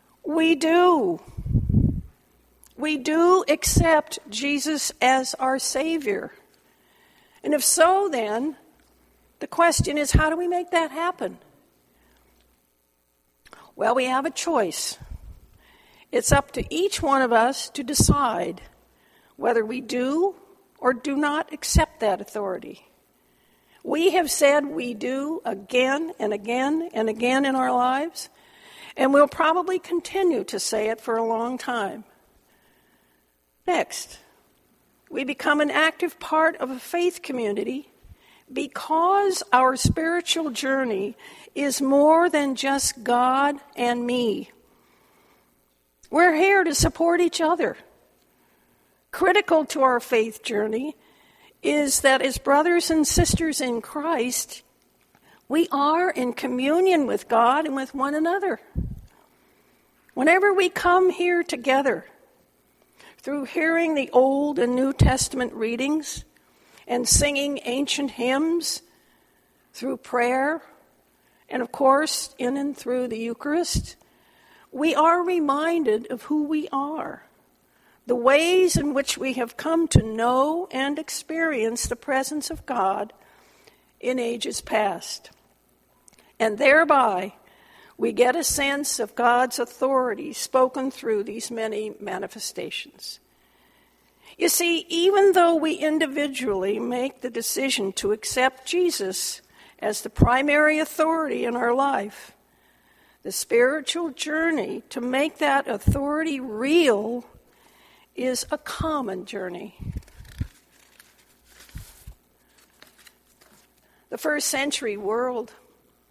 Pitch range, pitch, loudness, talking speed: 240-320 Hz, 275 Hz, -23 LUFS, 115 wpm